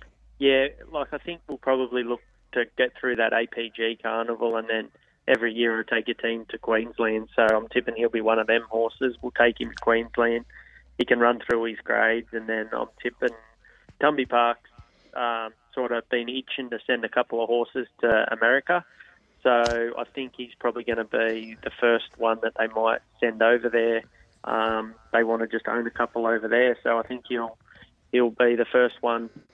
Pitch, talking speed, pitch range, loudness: 115 Hz, 200 wpm, 115-120 Hz, -25 LUFS